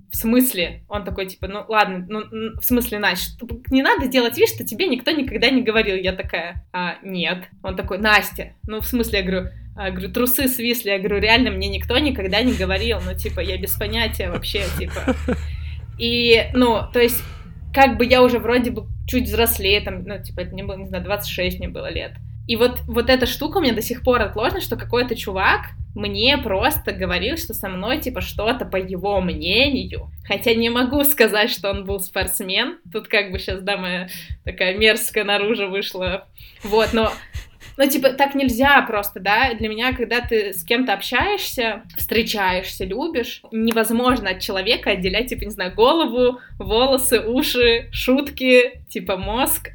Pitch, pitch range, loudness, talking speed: 225 Hz, 200-250 Hz, -19 LUFS, 180 wpm